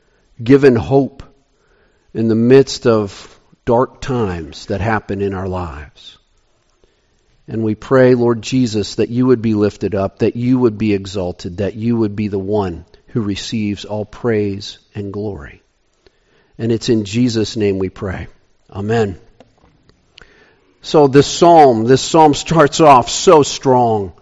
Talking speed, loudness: 145 wpm, -14 LUFS